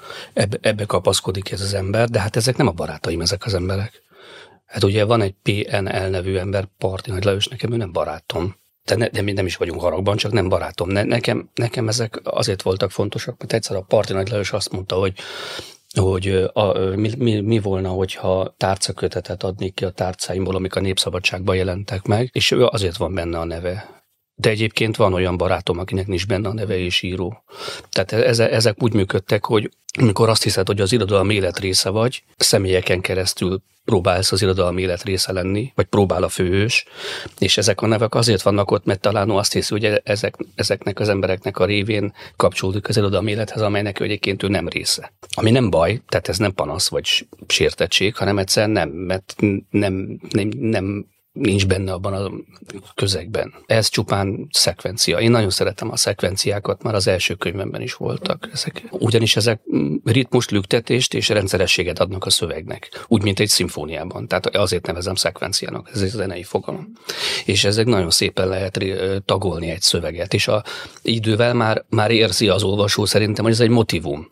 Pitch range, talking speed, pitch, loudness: 95-110 Hz, 180 wpm, 100 Hz, -19 LUFS